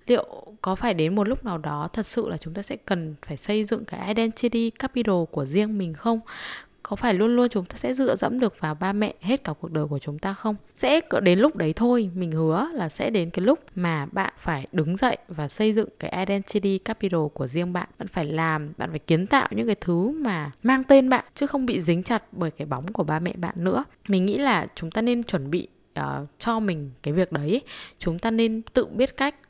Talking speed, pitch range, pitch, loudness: 240 wpm, 165-230 Hz, 195 Hz, -25 LUFS